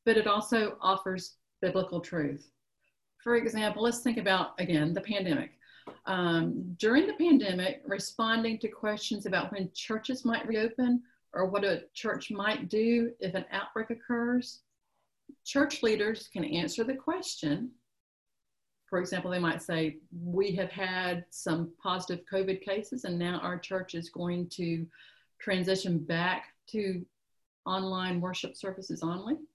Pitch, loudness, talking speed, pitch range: 190 Hz, -31 LUFS, 140 wpm, 180-230 Hz